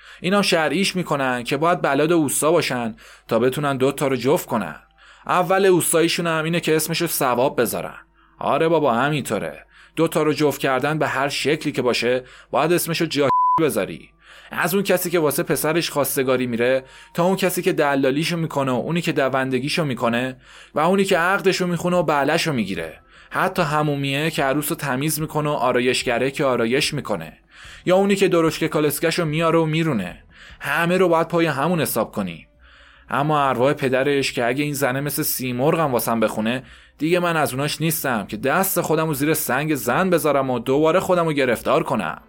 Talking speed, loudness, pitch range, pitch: 175 wpm, -20 LUFS, 135-170 Hz, 150 Hz